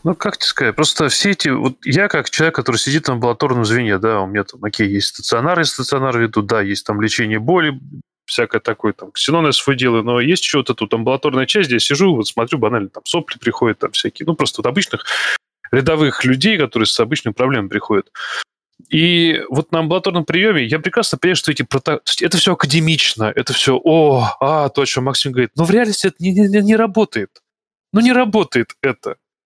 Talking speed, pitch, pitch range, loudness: 205 wpm, 145 Hz, 125-175 Hz, -16 LUFS